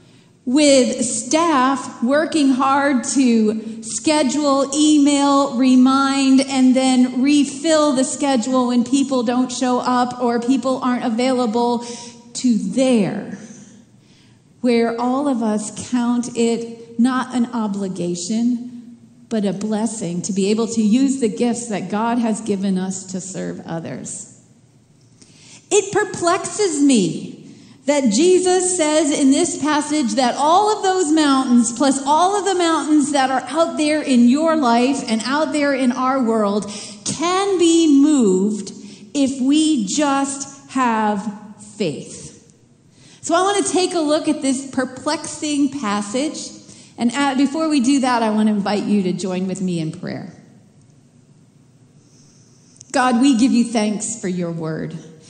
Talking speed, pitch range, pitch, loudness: 135 wpm, 220-285 Hz, 255 Hz, -18 LUFS